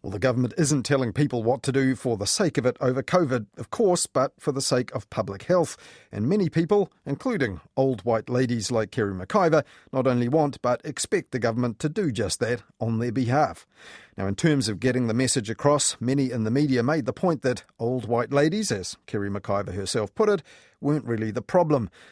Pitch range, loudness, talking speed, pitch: 115-145 Hz, -25 LUFS, 210 wpm, 130 Hz